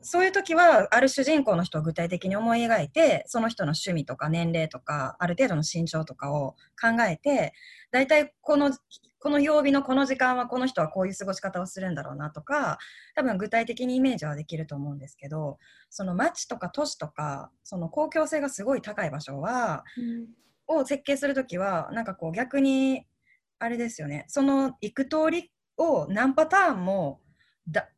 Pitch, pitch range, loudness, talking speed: 230 Hz, 165-280 Hz, -26 LUFS, 345 characters per minute